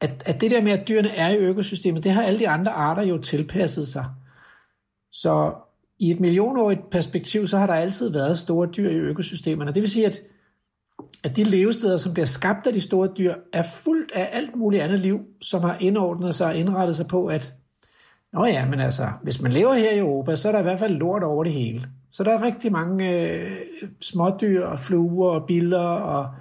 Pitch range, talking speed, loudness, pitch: 165-200 Hz, 215 wpm, -22 LUFS, 180 Hz